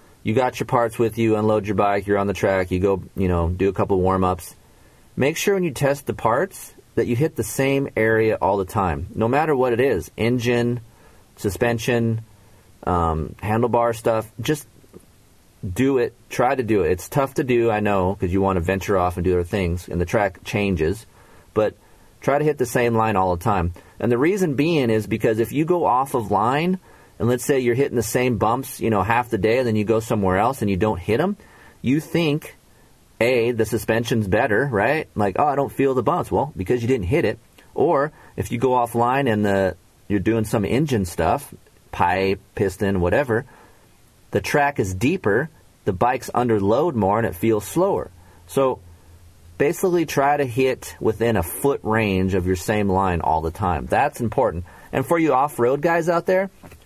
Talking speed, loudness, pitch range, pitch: 205 wpm, -21 LUFS, 95-125 Hz, 110 Hz